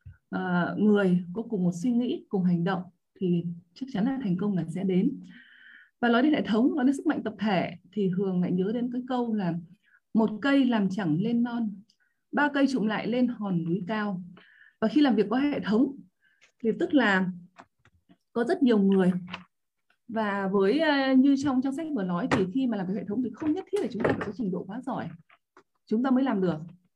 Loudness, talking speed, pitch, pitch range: -27 LUFS, 220 wpm, 215 Hz, 185-255 Hz